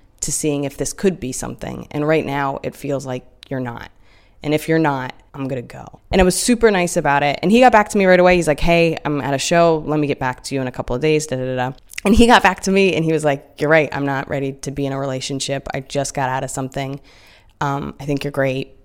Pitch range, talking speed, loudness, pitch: 135-160 Hz, 285 wpm, -18 LUFS, 140 Hz